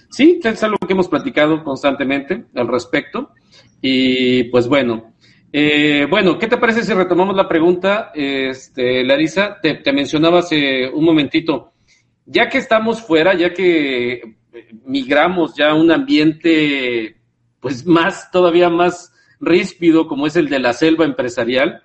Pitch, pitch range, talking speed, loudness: 165 Hz, 135-190 Hz, 145 wpm, -15 LUFS